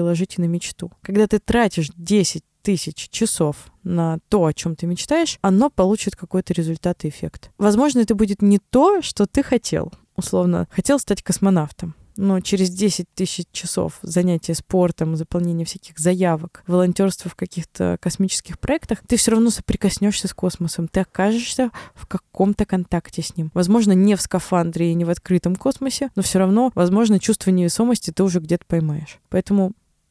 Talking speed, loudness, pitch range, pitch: 160 wpm, -20 LUFS, 170-210 Hz, 185 Hz